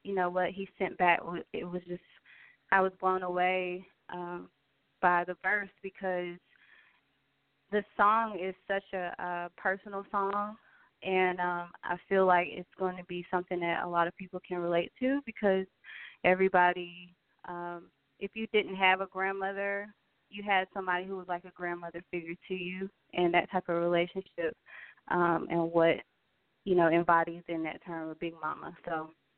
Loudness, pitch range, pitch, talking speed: -32 LUFS, 175-190 Hz, 180 Hz, 165 wpm